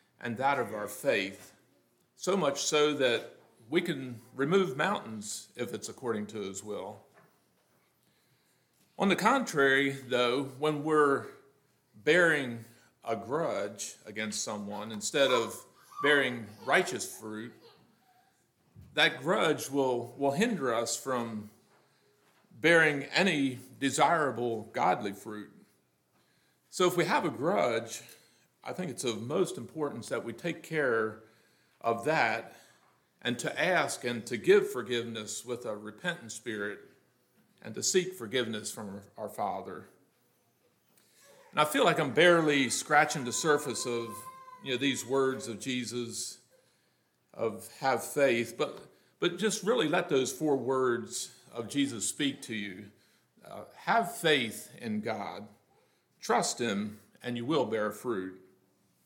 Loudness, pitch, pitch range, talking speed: -30 LUFS, 125 Hz, 110-150 Hz, 130 wpm